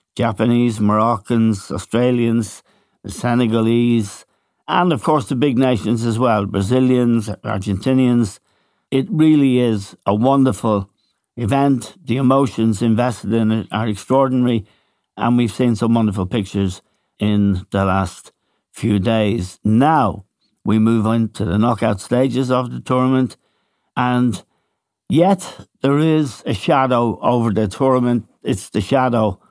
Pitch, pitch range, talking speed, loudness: 115 Hz, 105-125 Hz, 125 wpm, -17 LUFS